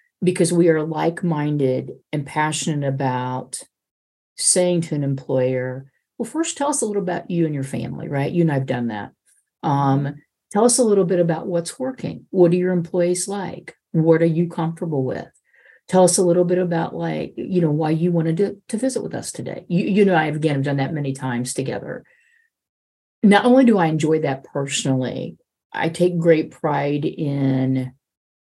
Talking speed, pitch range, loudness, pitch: 190 wpm, 135-180 Hz, -20 LUFS, 160 Hz